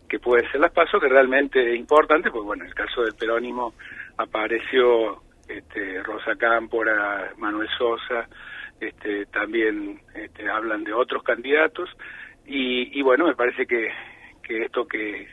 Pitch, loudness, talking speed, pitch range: 125 Hz, -22 LUFS, 150 wpm, 115-140 Hz